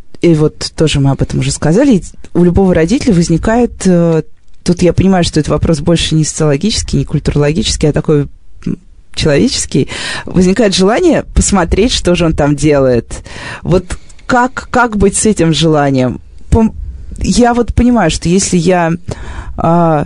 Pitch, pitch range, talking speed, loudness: 165 Hz, 145-185 Hz, 140 wpm, -11 LUFS